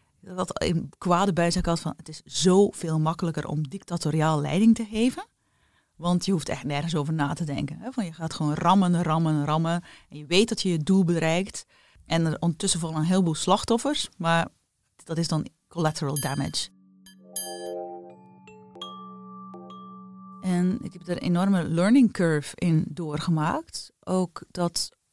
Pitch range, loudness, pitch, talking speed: 155-190 Hz, -25 LUFS, 170 Hz, 155 wpm